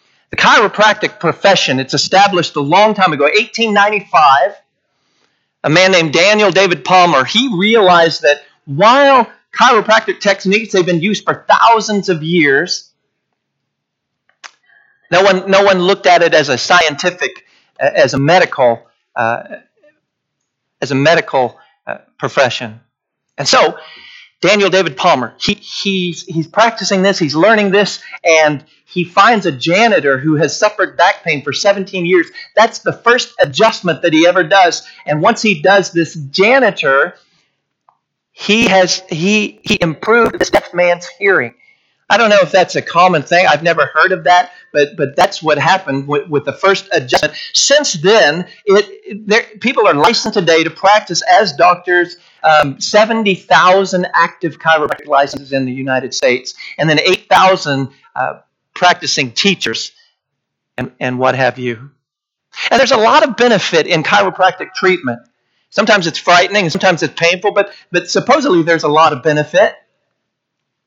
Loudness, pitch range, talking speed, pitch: -11 LUFS, 155-205 Hz, 150 wpm, 180 Hz